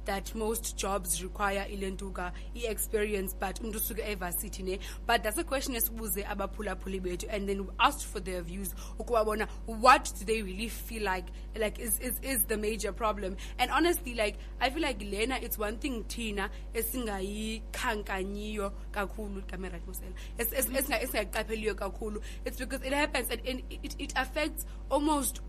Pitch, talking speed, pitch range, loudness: 215 Hz, 170 wpm, 195-245 Hz, -32 LUFS